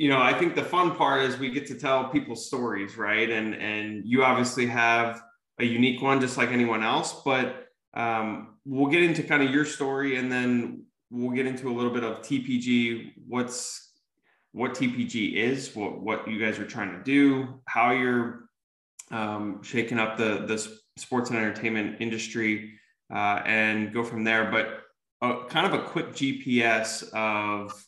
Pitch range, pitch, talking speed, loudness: 110-135 Hz, 120 Hz, 175 wpm, -26 LUFS